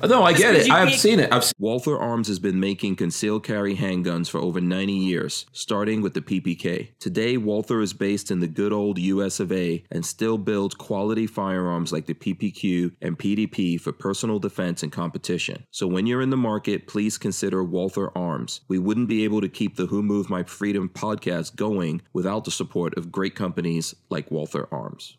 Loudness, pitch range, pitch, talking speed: -24 LUFS, 90-105 Hz, 100 Hz, 200 wpm